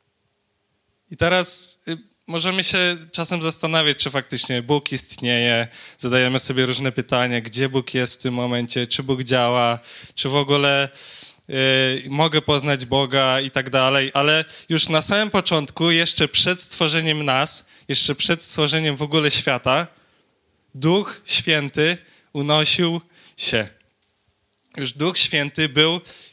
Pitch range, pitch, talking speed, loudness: 130-160 Hz, 140 Hz, 130 wpm, -19 LUFS